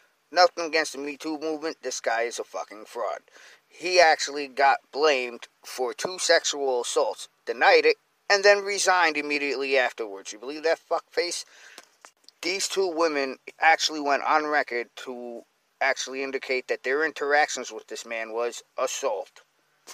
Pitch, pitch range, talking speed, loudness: 150 Hz, 130-190 Hz, 150 wpm, -25 LUFS